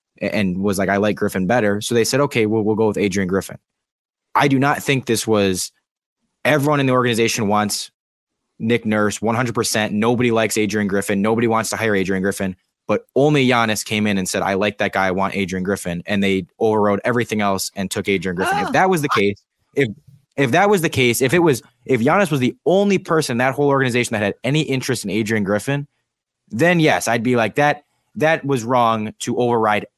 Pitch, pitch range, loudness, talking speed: 115 Hz, 100-135 Hz, -18 LUFS, 220 wpm